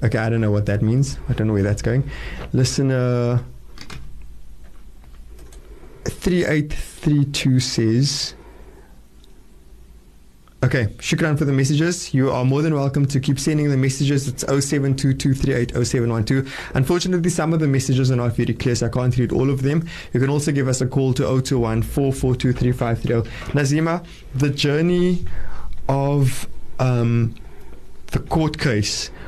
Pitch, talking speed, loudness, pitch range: 130 Hz, 135 wpm, -20 LUFS, 115-140 Hz